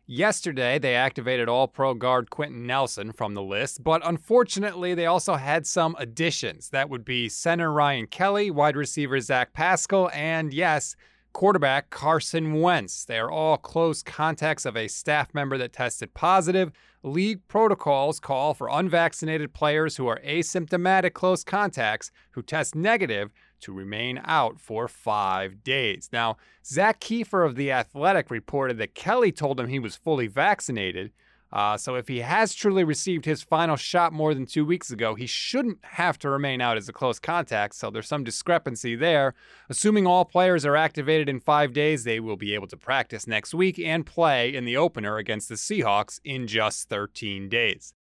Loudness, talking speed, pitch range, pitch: -25 LUFS, 170 wpm, 125-170 Hz, 150 Hz